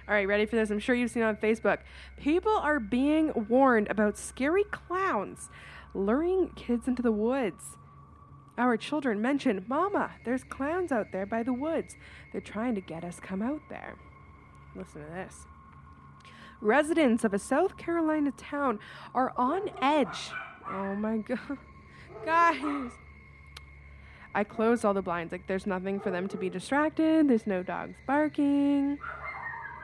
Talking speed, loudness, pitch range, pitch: 155 wpm, -29 LUFS, 195-290 Hz, 240 Hz